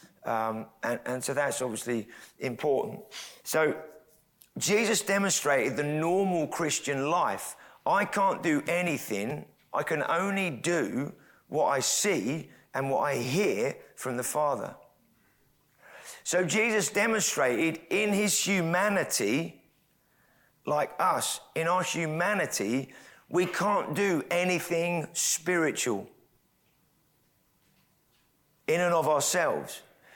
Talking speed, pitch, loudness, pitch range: 105 wpm, 170 Hz, -28 LUFS, 140-185 Hz